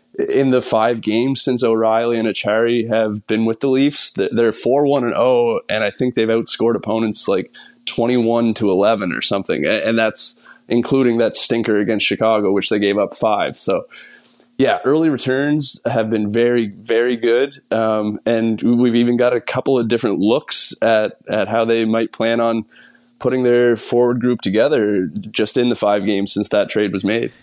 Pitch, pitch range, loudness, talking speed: 115 Hz, 110-125 Hz, -17 LUFS, 180 wpm